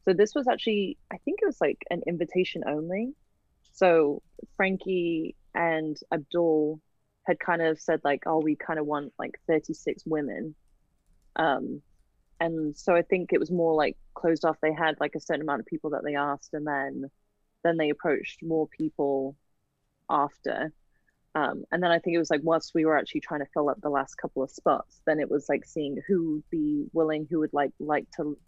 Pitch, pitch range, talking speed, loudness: 160 Hz, 145-170 Hz, 200 wpm, -28 LUFS